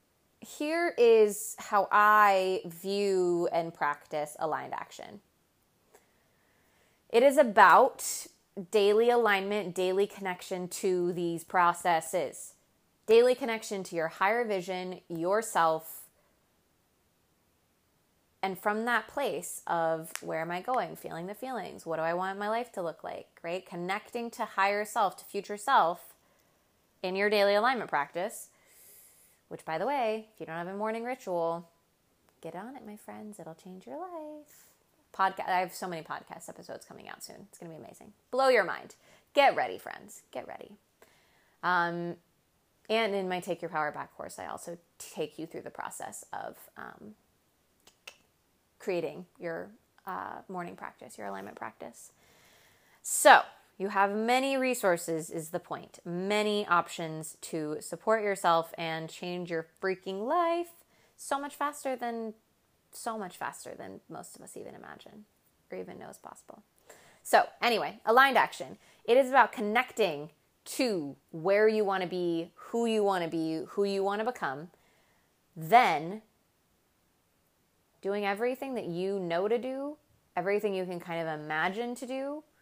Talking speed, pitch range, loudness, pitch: 145 wpm, 170-220 Hz, -29 LUFS, 190 Hz